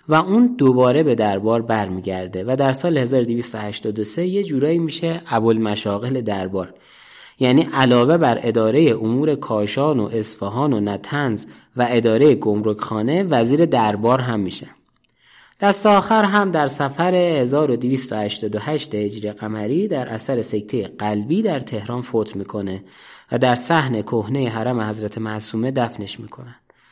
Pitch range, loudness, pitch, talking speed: 105-145 Hz, -19 LUFS, 120 Hz, 130 wpm